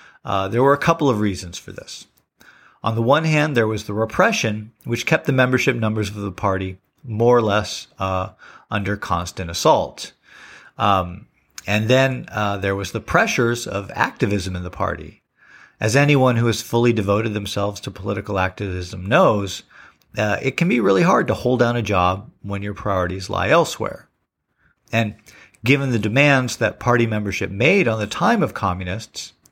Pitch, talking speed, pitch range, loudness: 105 Hz, 175 wpm, 95-120 Hz, -20 LUFS